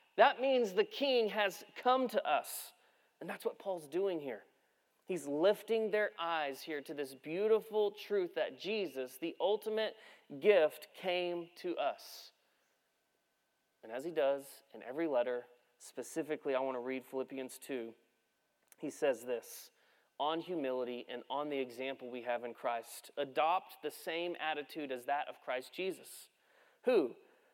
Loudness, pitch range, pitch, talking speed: -37 LUFS, 130-215 Hz, 165 Hz, 150 wpm